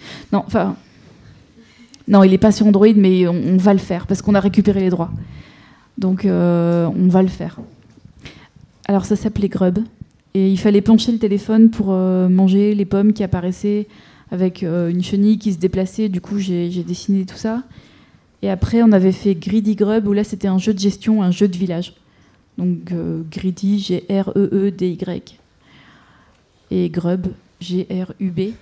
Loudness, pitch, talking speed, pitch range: -17 LUFS, 190 Hz, 170 wpm, 180-205 Hz